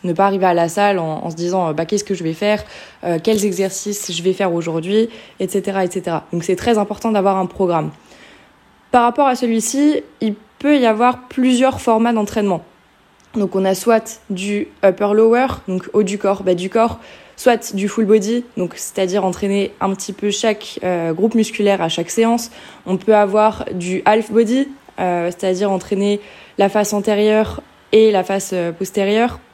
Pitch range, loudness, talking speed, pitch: 190-225 Hz, -17 LUFS, 180 wpm, 205 Hz